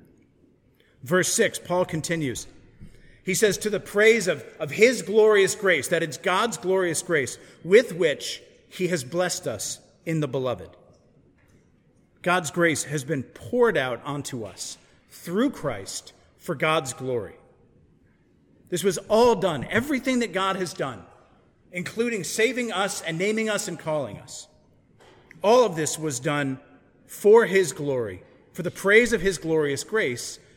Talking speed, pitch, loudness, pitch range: 145 wpm, 180 Hz, -24 LUFS, 155-215 Hz